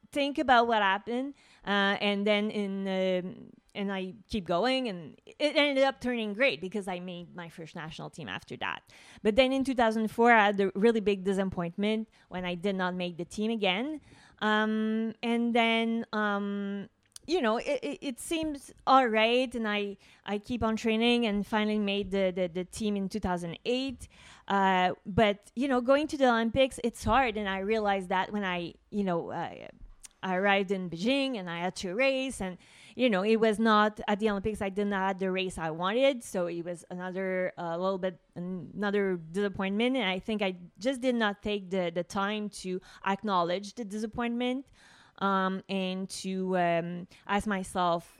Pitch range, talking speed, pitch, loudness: 185-230 Hz, 185 wpm, 205 Hz, -29 LUFS